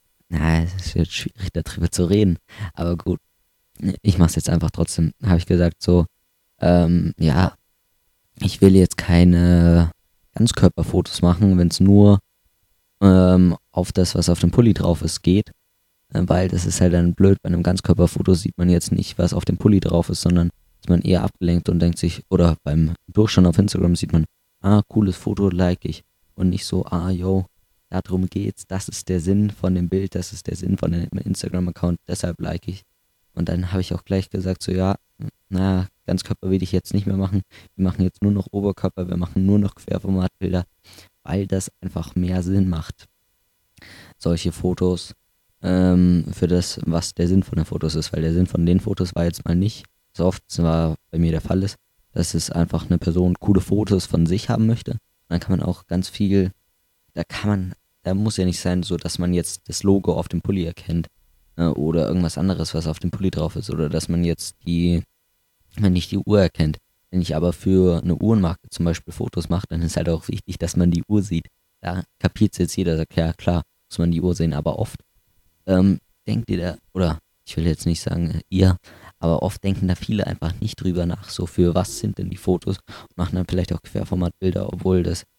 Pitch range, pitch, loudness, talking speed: 85-95 Hz, 90 Hz, -21 LUFS, 205 wpm